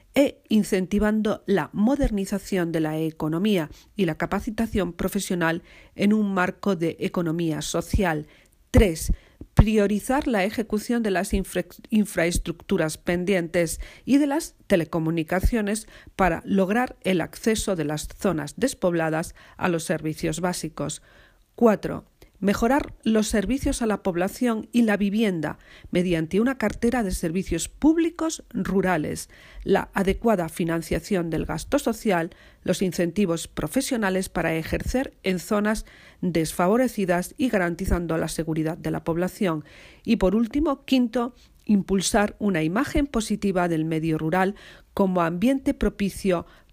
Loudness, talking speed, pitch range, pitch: -24 LUFS, 120 wpm, 170-220 Hz, 195 Hz